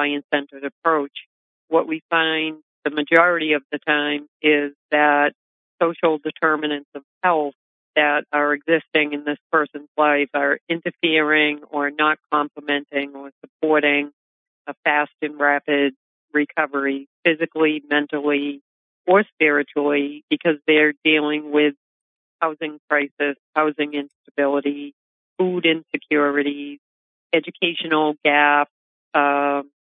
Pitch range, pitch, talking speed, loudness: 145-155 Hz, 150 Hz, 105 wpm, -20 LUFS